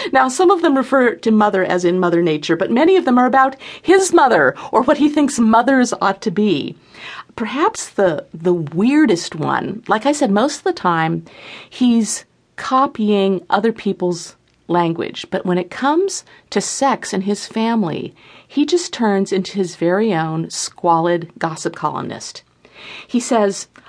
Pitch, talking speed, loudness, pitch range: 210 Hz, 165 wpm, -17 LUFS, 180-265 Hz